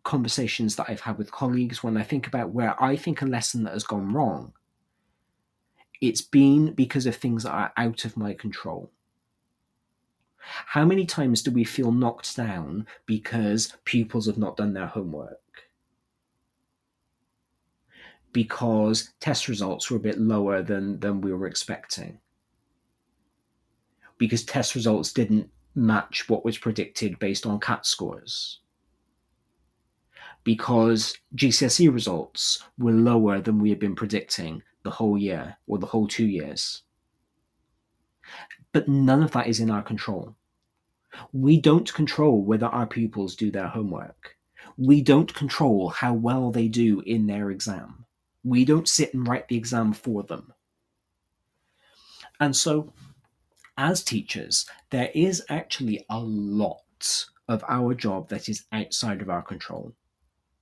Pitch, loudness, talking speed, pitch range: 115 Hz, -25 LUFS, 140 wpm, 105-130 Hz